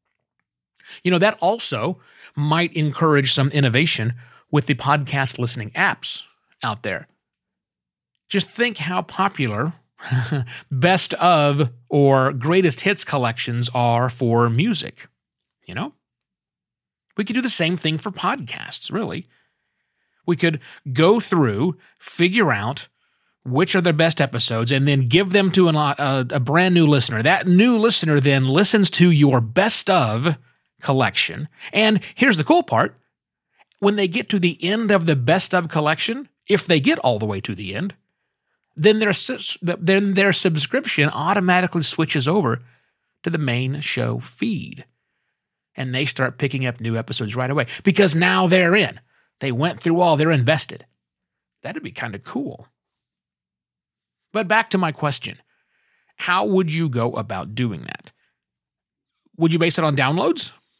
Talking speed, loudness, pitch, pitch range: 150 wpm, -19 LUFS, 155 Hz, 130-185 Hz